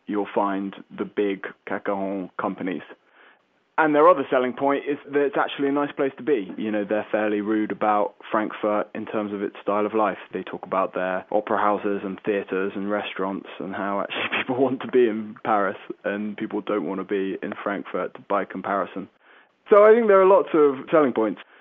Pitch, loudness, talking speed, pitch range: 105 Hz, -23 LUFS, 200 wpm, 100-140 Hz